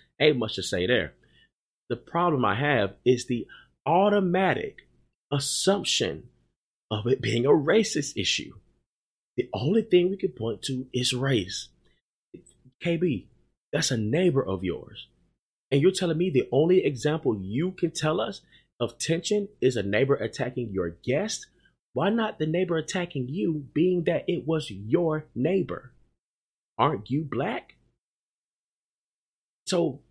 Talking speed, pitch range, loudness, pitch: 140 wpm, 125-180 Hz, -26 LUFS, 150 Hz